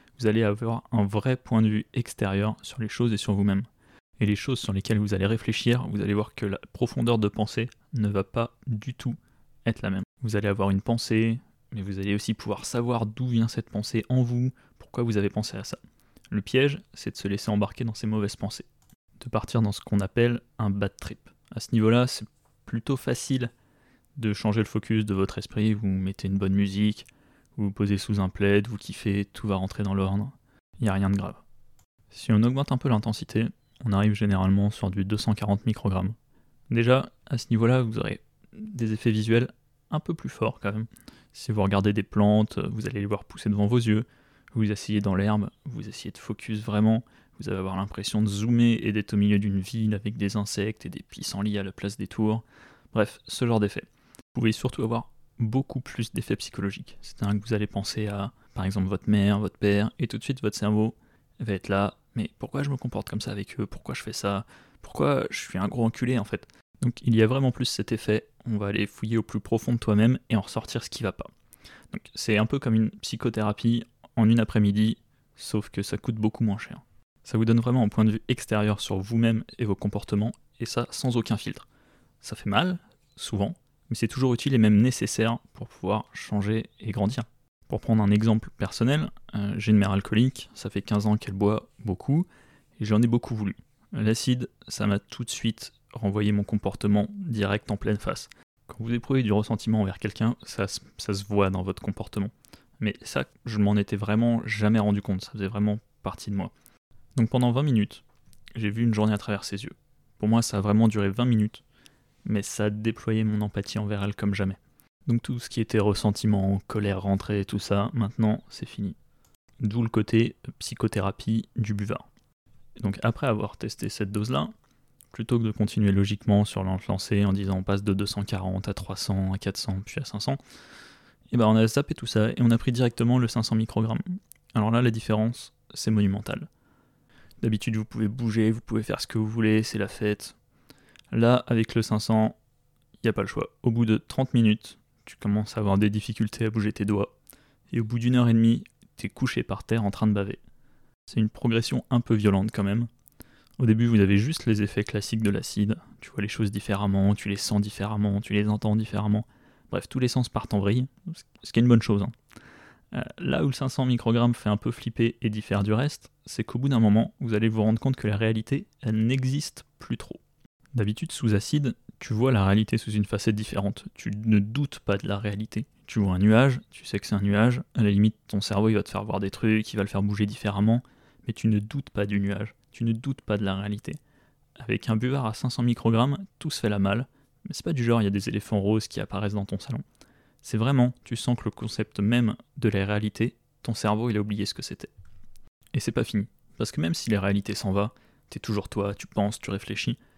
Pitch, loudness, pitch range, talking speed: 110 Hz, -27 LUFS, 105-120 Hz, 220 wpm